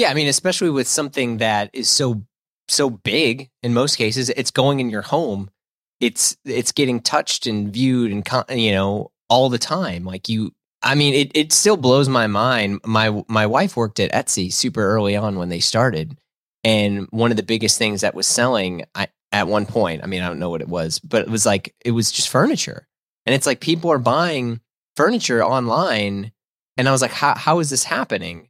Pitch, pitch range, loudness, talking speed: 115 Hz, 105-135 Hz, -18 LUFS, 210 wpm